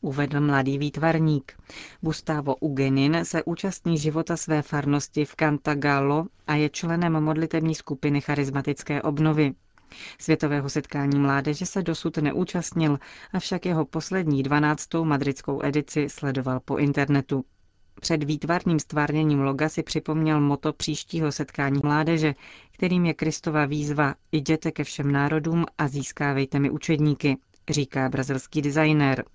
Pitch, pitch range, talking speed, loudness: 150 Hz, 140-160 Hz, 120 wpm, -25 LUFS